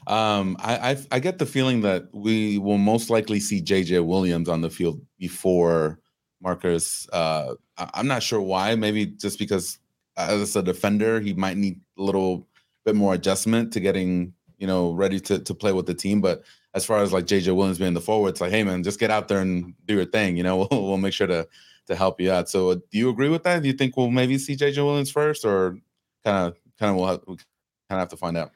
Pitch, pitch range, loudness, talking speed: 100 Hz, 90-110 Hz, -23 LUFS, 235 wpm